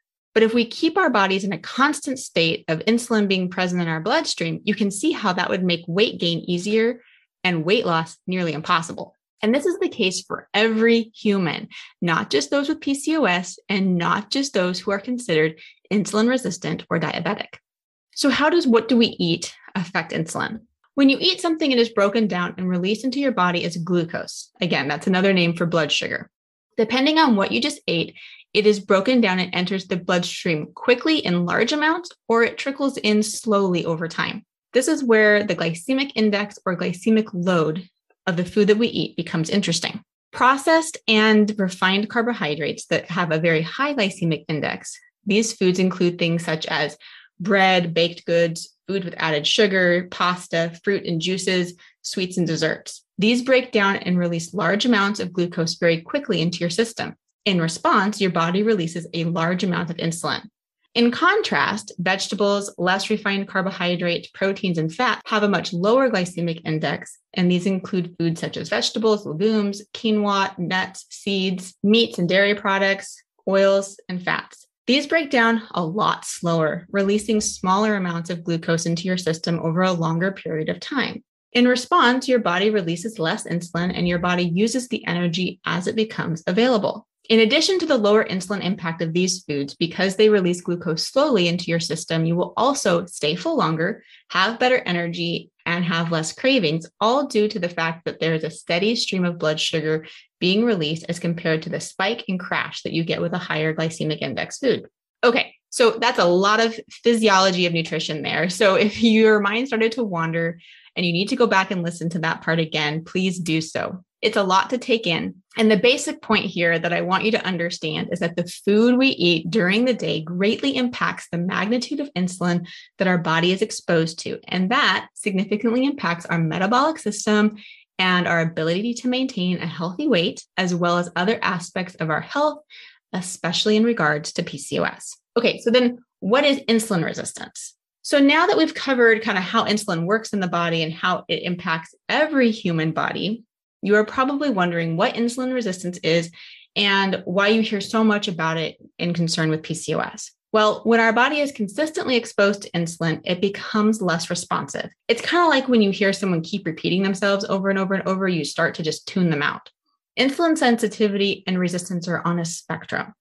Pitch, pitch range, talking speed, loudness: 195 Hz, 170-225 Hz, 185 wpm, -21 LUFS